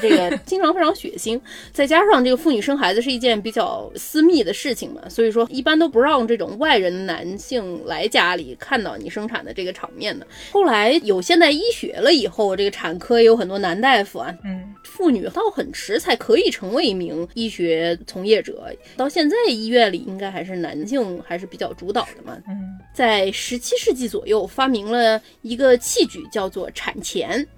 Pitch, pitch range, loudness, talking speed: 240 Hz, 195-315 Hz, -19 LUFS, 295 characters per minute